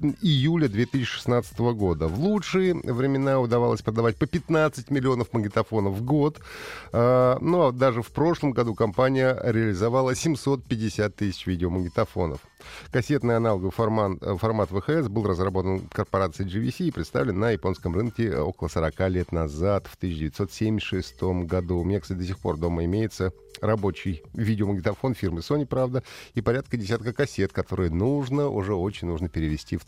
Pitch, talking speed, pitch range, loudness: 110 Hz, 145 wpm, 95-130 Hz, -25 LUFS